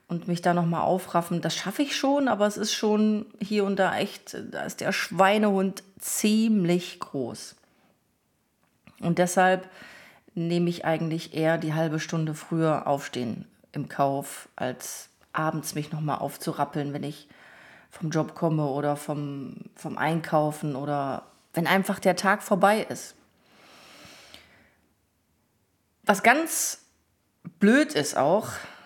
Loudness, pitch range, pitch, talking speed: -26 LUFS, 155-200 Hz, 175 Hz, 130 wpm